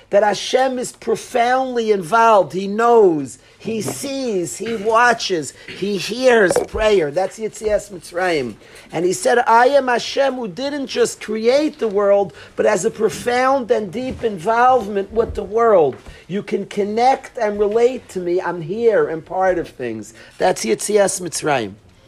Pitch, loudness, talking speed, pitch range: 215 Hz, -18 LUFS, 150 wpm, 190-240 Hz